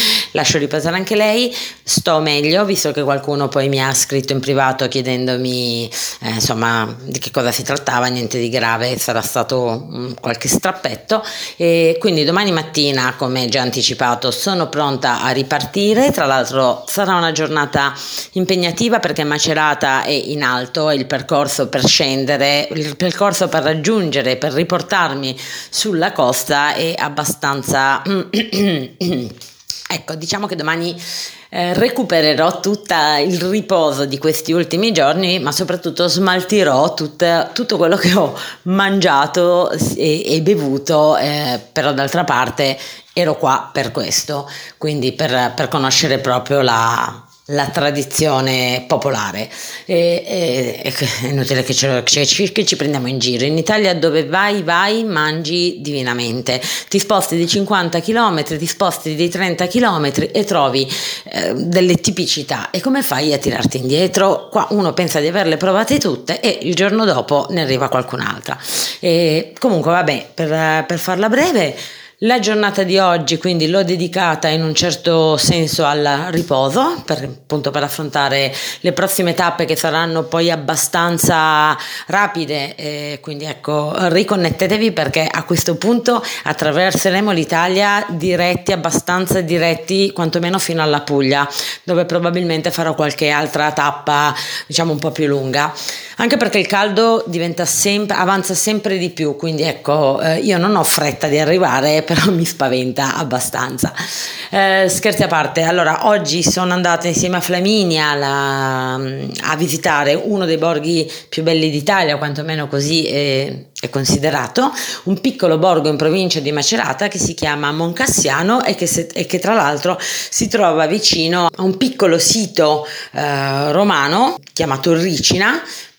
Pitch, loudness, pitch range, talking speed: 160 Hz, -15 LUFS, 145-185 Hz, 145 wpm